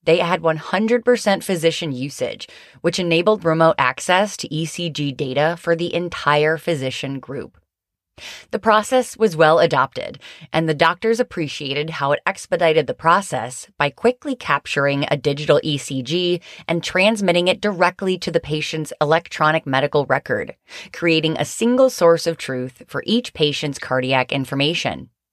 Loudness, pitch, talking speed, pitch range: -19 LUFS, 165 Hz, 135 wpm, 145-185 Hz